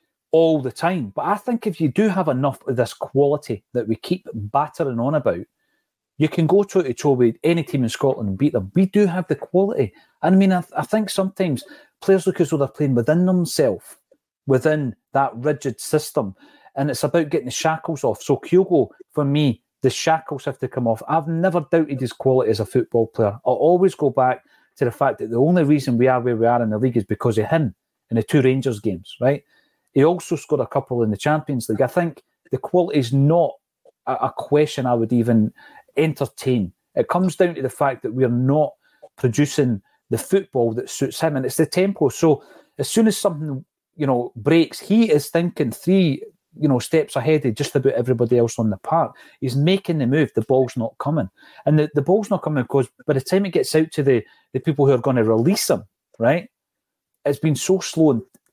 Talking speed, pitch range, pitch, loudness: 220 wpm, 125-170 Hz, 145 Hz, -20 LUFS